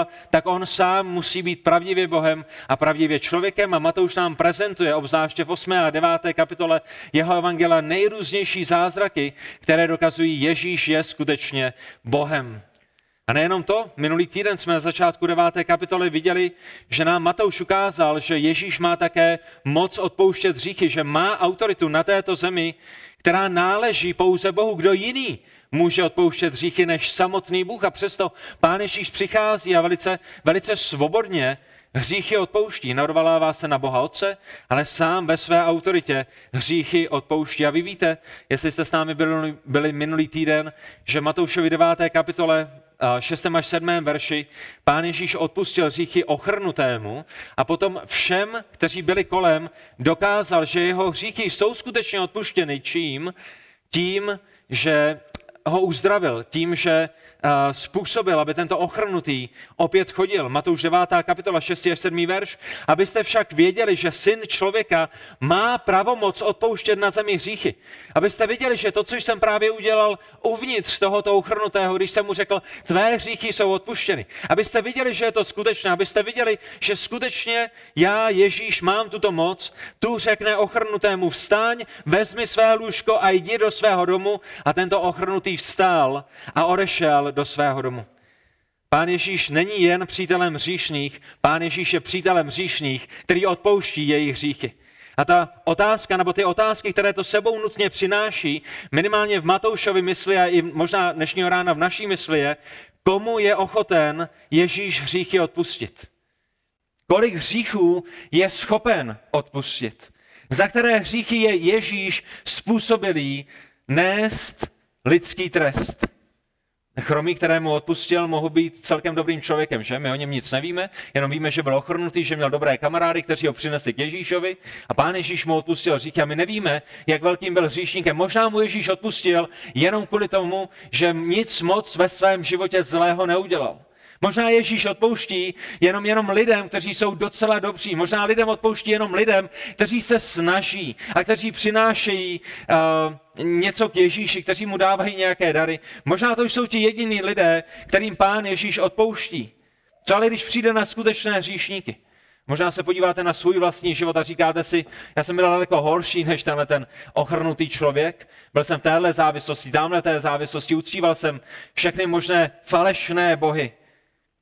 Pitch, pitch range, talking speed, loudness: 180 Hz, 160-205 Hz, 150 wpm, -21 LUFS